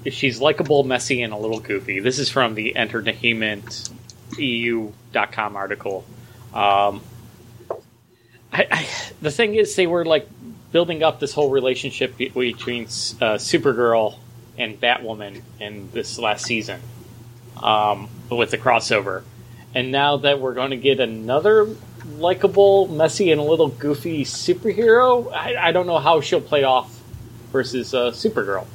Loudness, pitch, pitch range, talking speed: -20 LUFS, 120 Hz, 115-145 Hz, 140 wpm